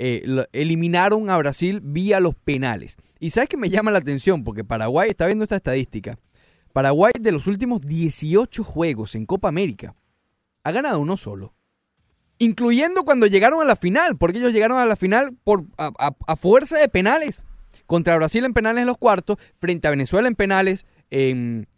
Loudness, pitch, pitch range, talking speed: -19 LUFS, 175 Hz, 135-215 Hz, 180 wpm